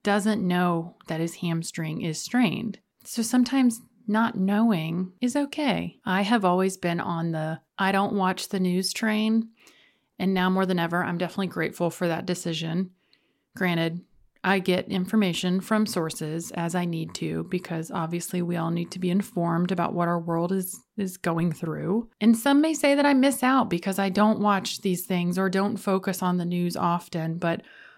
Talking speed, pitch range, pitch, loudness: 180 wpm, 170-215 Hz, 185 Hz, -26 LUFS